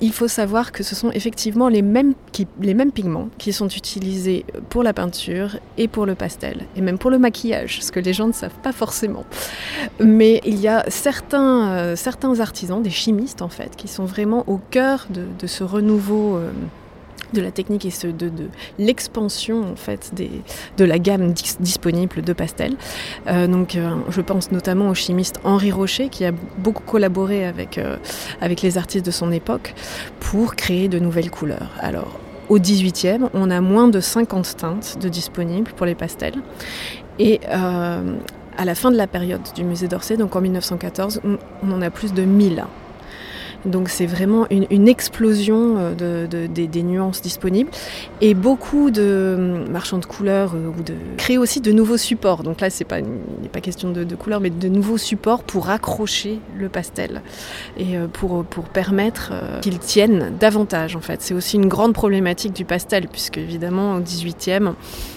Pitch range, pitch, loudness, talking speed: 180-220 Hz, 195 Hz, -19 LUFS, 185 wpm